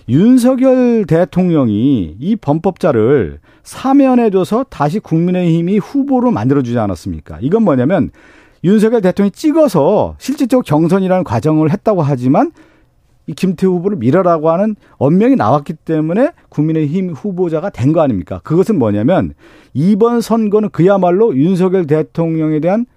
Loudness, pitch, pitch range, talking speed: -13 LUFS, 185 Hz, 155-220 Hz, 335 characters per minute